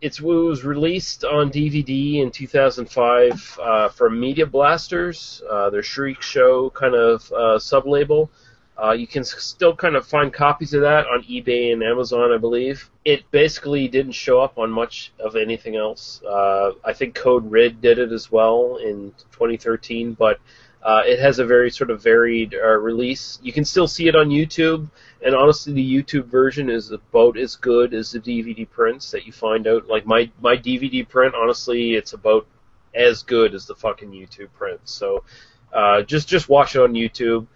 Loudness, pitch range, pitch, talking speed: -18 LUFS, 115-150 Hz, 125 Hz, 180 wpm